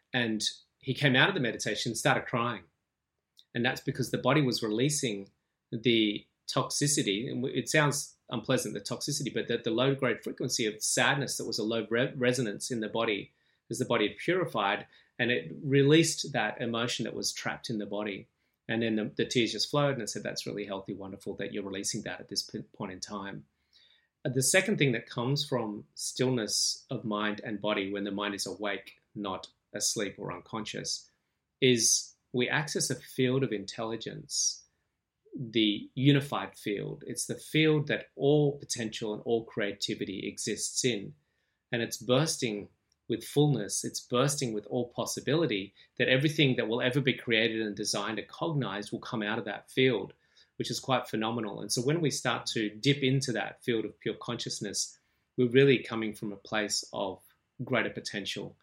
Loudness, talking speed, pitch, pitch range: -30 LUFS, 180 wpm, 120 Hz, 105-135 Hz